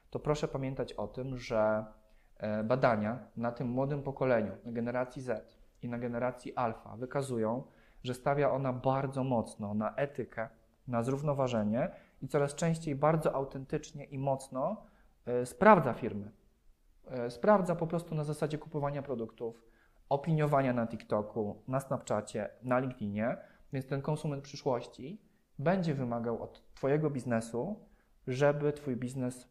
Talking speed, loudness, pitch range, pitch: 130 wpm, -34 LUFS, 115-145 Hz, 130 Hz